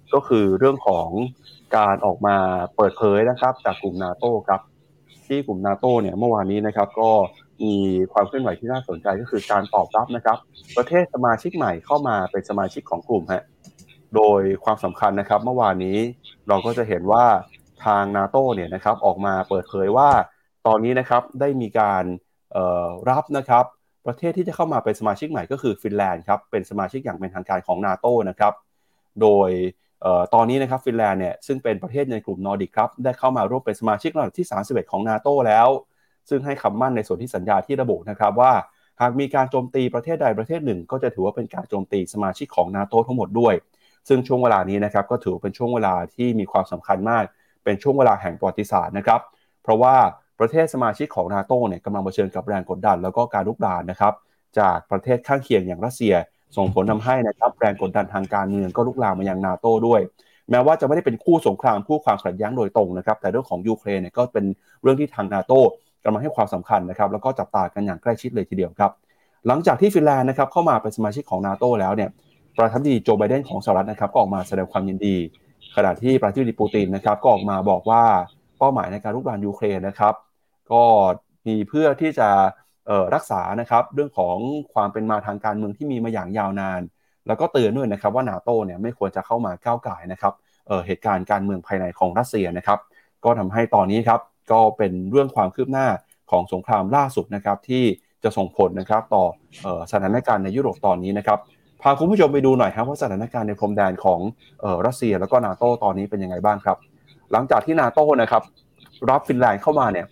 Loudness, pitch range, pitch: -21 LUFS, 100-125 Hz, 110 Hz